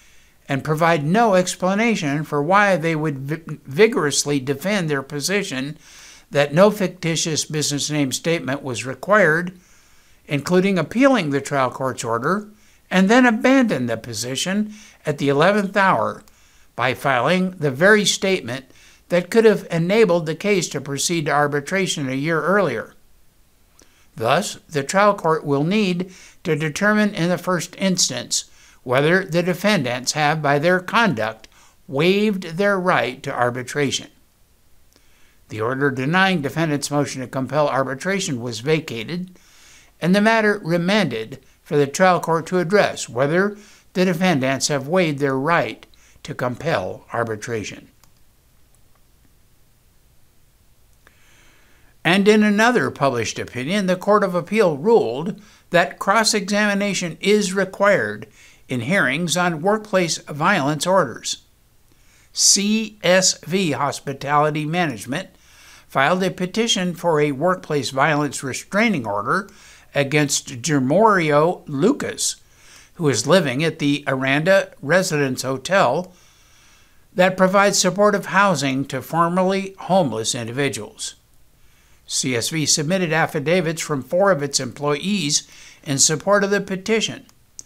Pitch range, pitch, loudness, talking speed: 140-190 Hz, 165 Hz, -19 LUFS, 115 wpm